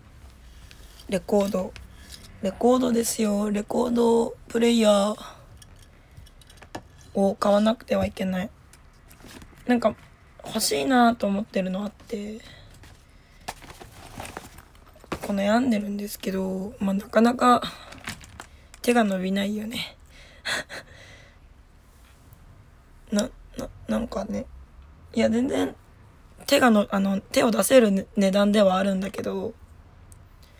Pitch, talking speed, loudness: 200 Hz, 200 characters per minute, -24 LUFS